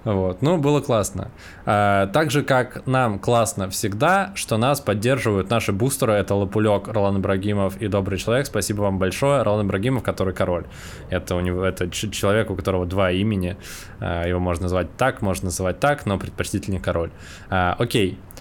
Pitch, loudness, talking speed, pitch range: 100 Hz, -22 LUFS, 170 wpm, 95-115 Hz